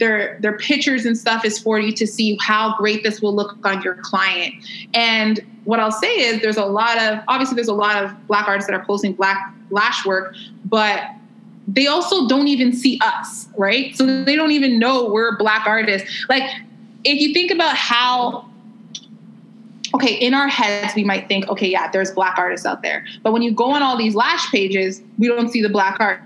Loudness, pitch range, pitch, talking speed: -17 LUFS, 205-245 Hz, 220 Hz, 210 wpm